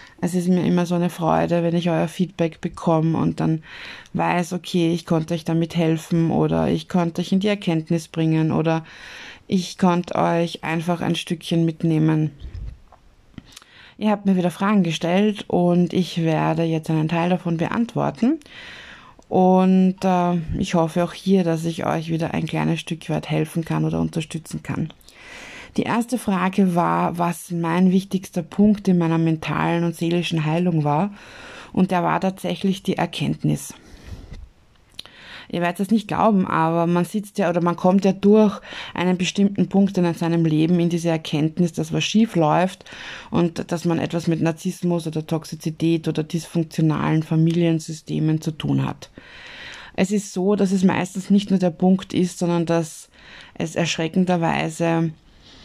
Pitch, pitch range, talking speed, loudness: 170 Hz, 165-185 Hz, 160 wpm, -21 LUFS